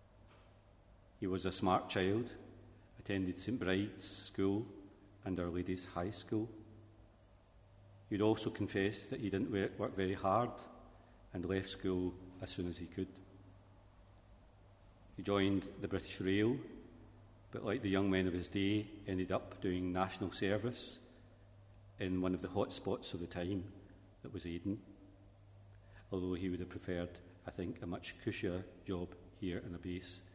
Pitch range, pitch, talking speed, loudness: 90-100 Hz, 95 Hz, 150 wpm, -40 LUFS